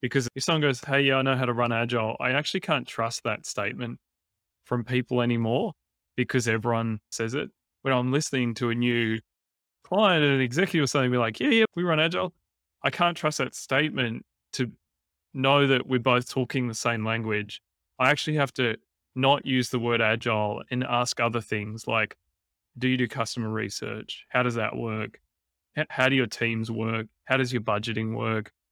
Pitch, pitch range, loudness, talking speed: 120 Hz, 110-135 Hz, -26 LUFS, 190 wpm